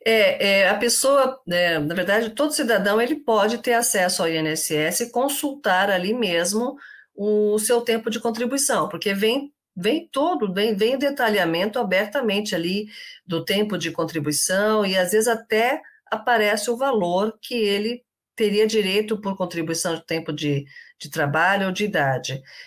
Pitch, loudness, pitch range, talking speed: 210 Hz, -21 LUFS, 180-235 Hz, 155 wpm